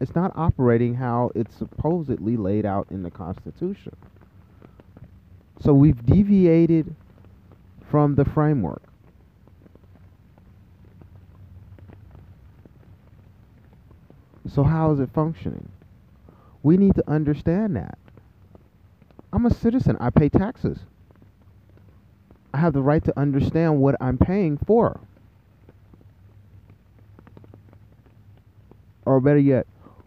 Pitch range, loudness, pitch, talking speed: 95-140 Hz, -21 LUFS, 105 Hz, 90 wpm